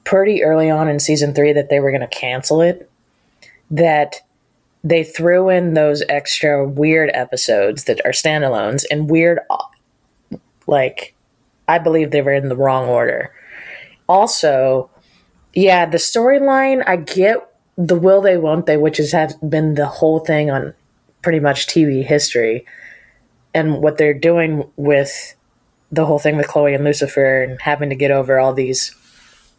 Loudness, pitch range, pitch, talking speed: -15 LUFS, 140-165 Hz, 150 Hz, 155 wpm